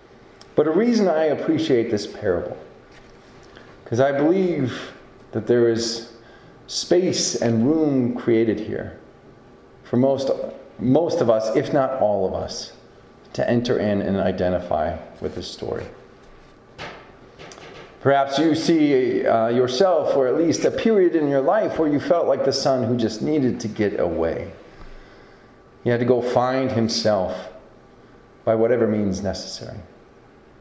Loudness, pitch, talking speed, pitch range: -21 LUFS, 125 Hz, 140 wpm, 115-145 Hz